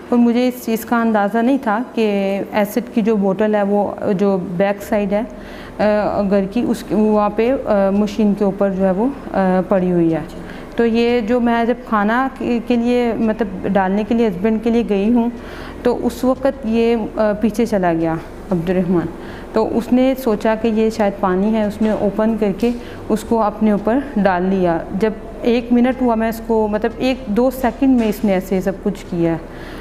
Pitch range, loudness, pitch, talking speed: 200-235 Hz, -17 LUFS, 220 Hz, 205 wpm